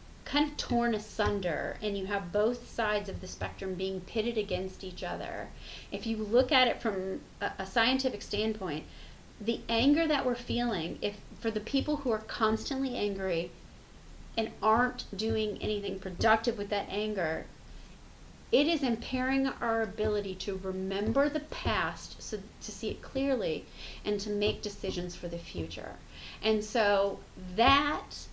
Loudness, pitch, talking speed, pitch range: -31 LUFS, 215 Hz, 150 wpm, 200-240 Hz